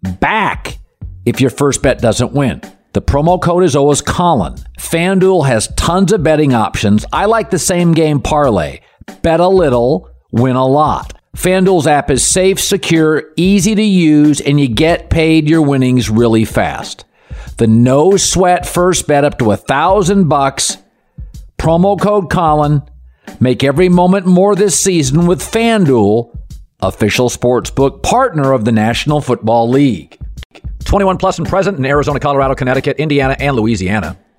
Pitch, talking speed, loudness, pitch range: 145 Hz, 155 wpm, -12 LUFS, 120-180 Hz